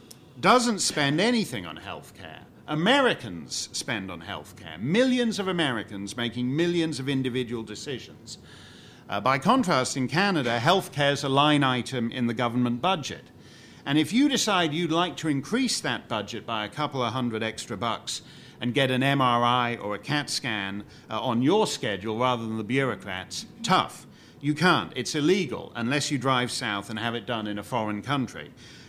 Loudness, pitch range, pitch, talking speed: -26 LUFS, 115-150 Hz, 130 Hz, 175 wpm